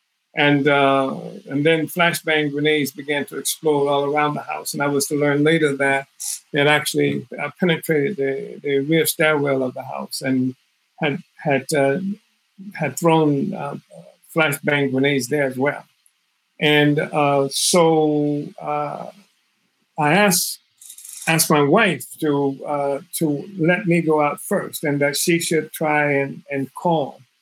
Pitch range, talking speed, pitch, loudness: 140-160 Hz, 145 wpm, 150 Hz, -19 LUFS